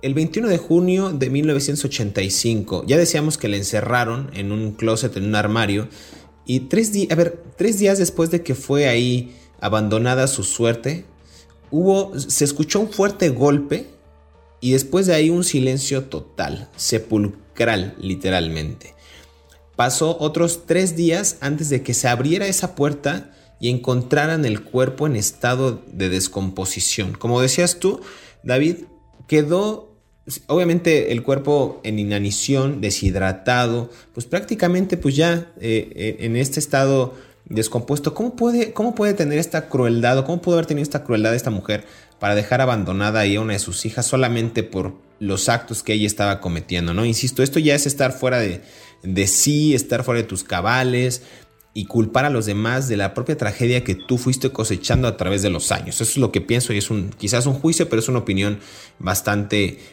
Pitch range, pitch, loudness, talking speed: 105-150 Hz, 125 Hz, -20 LUFS, 170 wpm